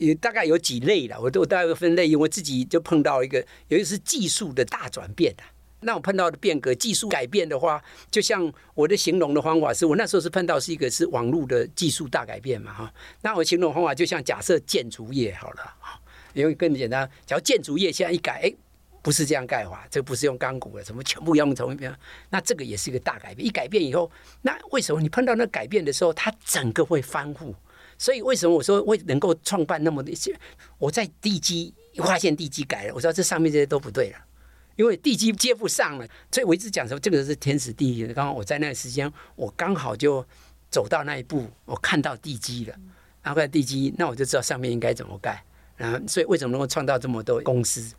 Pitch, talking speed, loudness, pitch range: 155 Hz, 350 characters per minute, -24 LUFS, 135-180 Hz